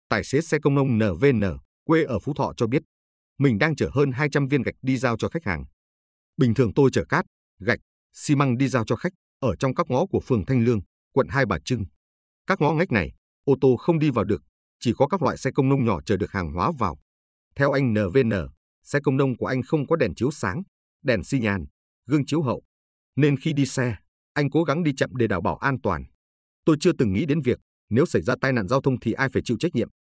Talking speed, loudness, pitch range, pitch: 245 wpm, -24 LUFS, 90-140 Hz, 125 Hz